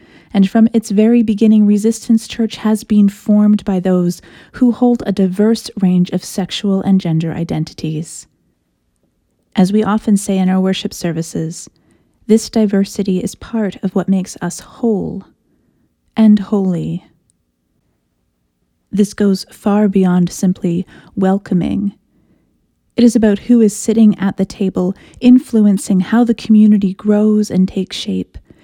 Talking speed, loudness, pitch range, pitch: 135 wpm, -14 LUFS, 180-215 Hz, 195 Hz